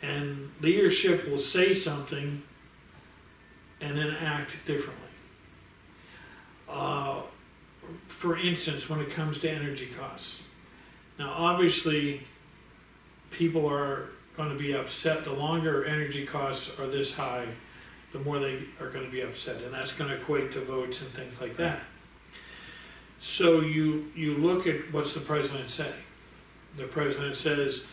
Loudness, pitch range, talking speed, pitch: -30 LUFS, 135-155 Hz, 135 wpm, 145 Hz